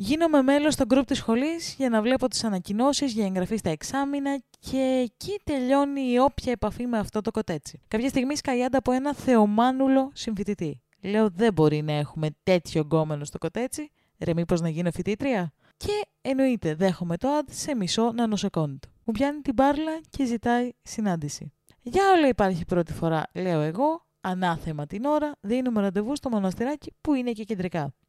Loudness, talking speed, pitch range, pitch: -26 LUFS, 170 wpm, 180-270 Hz, 230 Hz